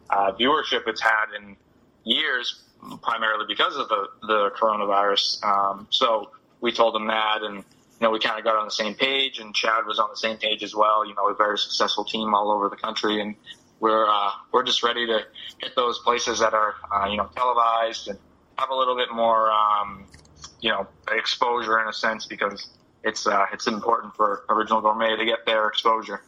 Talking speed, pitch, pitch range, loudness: 205 wpm, 110 Hz, 100-110 Hz, -23 LUFS